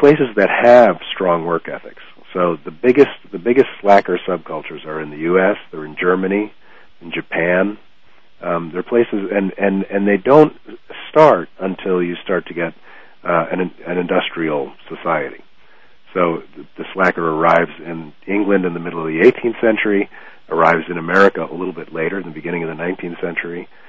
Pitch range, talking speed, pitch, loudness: 85-100 Hz, 175 wpm, 90 Hz, -16 LUFS